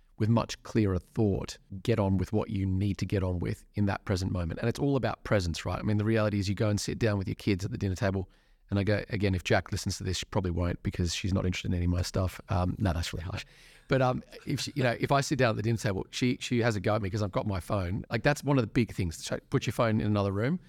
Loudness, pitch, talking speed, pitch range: -30 LUFS, 105 Hz, 305 wpm, 95-115 Hz